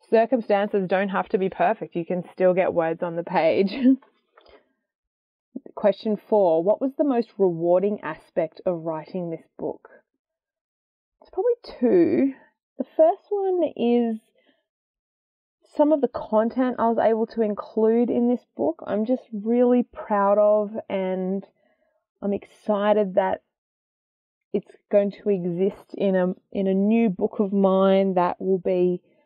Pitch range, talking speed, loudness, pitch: 190-245 Hz, 140 wpm, -23 LUFS, 210 Hz